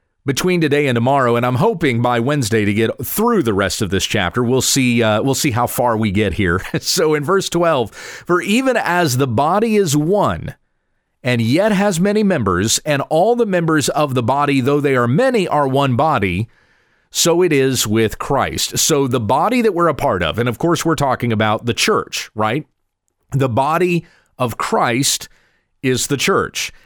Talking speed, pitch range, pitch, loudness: 190 wpm, 115-165 Hz, 135 Hz, -16 LUFS